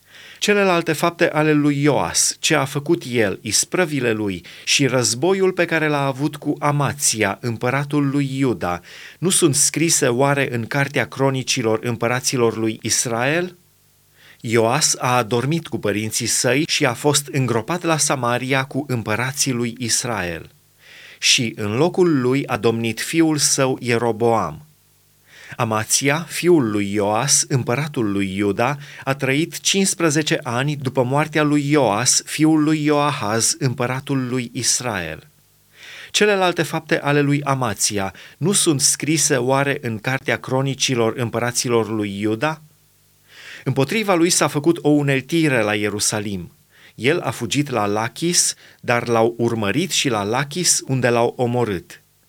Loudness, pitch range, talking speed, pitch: -19 LUFS, 115-150 Hz, 130 wpm, 135 Hz